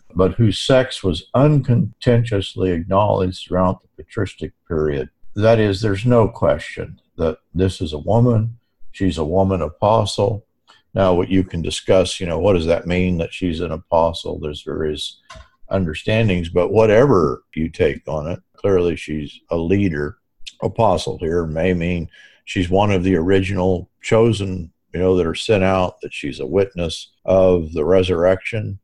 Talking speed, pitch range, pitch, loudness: 155 wpm, 85-100 Hz, 95 Hz, -19 LUFS